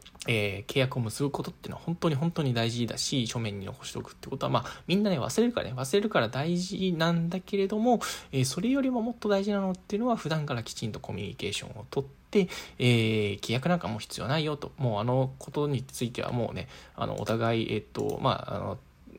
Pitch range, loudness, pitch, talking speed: 115-190 Hz, -30 LUFS, 145 Hz, 455 characters per minute